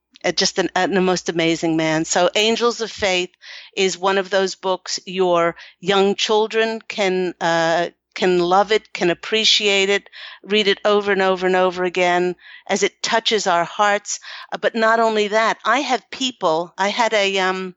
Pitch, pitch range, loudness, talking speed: 195 Hz, 180-210 Hz, -18 LUFS, 180 wpm